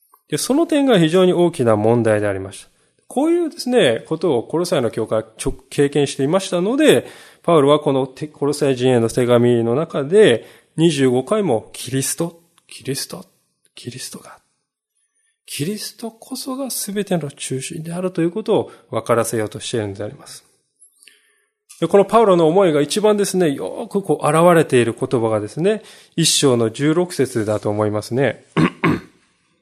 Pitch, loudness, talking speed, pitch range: 155 Hz, -18 LUFS, 315 characters per minute, 125-205 Hz